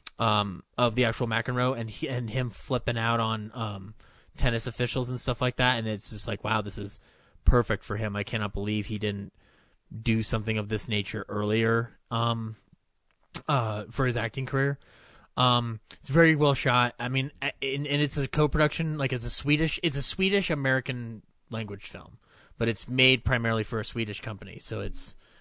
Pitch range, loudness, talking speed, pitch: 110-130 Hz, -27 LUFS, 180 wpm, 115 Hz